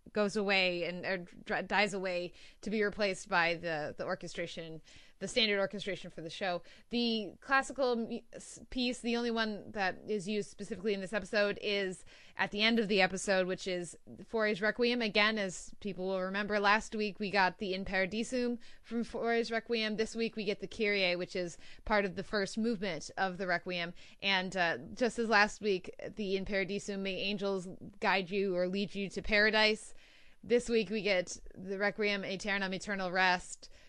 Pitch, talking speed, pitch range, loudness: 200 Hz, 180 wpm, 185-220 Hz, -33 LUFS